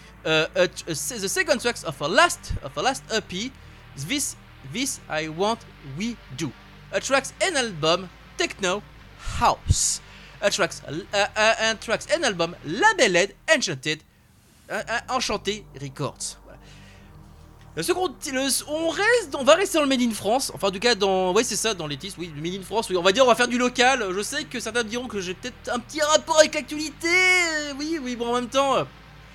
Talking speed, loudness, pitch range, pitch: 195 wpm, -23 LUFS, 165-275 Hz, 220 Hz